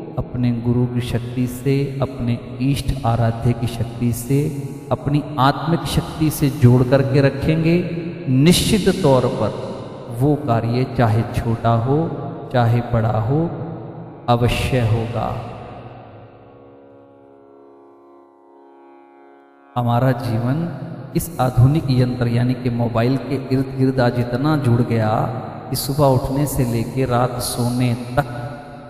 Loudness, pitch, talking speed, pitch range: -19 LUFS, 125 Hz, 110 wpm, 120-140 Hz